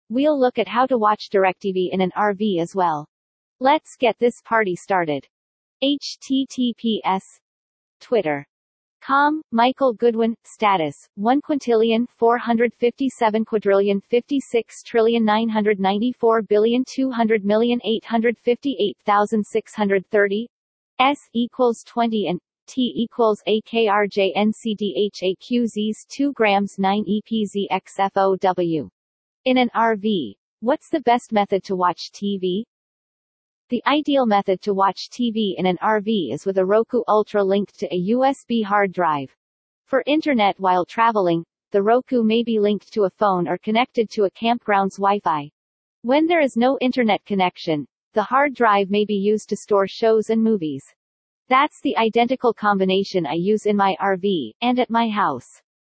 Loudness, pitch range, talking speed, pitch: -20 LUFS, 195-240 Hz, 135 wpm, 215 Hz